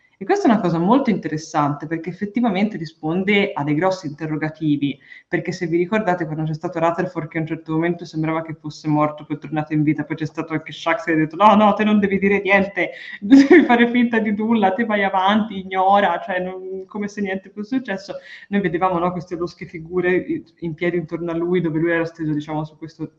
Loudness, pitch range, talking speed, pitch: -19 LUFS, 160-200 Hz, 225 wpm, 175 Hz